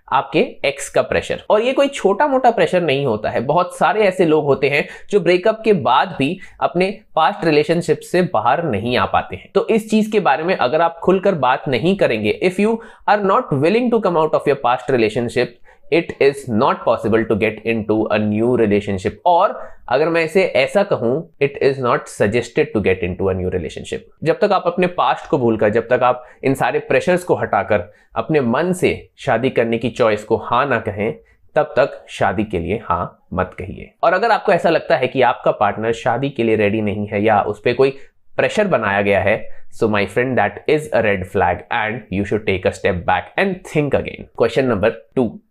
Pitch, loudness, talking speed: 140 Hz, -17 LUFS, 210 wpm